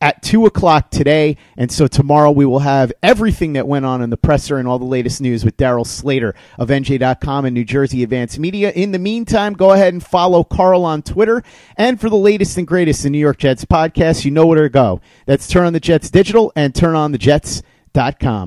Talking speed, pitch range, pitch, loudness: 220 wpm, 135-180 Hz, 150 Hz, -14 LUFS